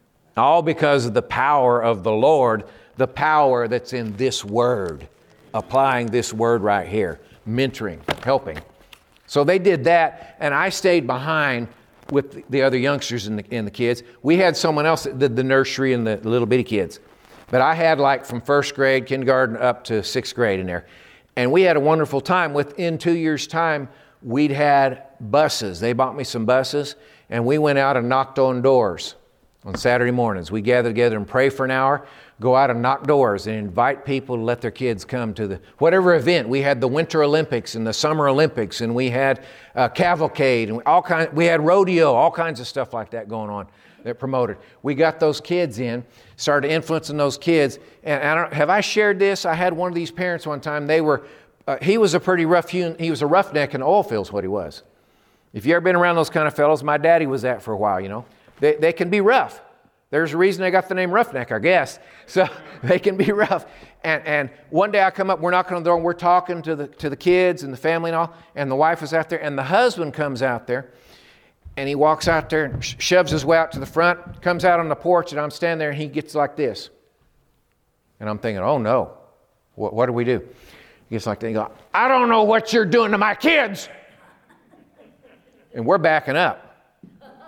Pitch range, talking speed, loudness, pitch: 125-165 Hz, 225 wpm, -20 LUFS, 145 Hz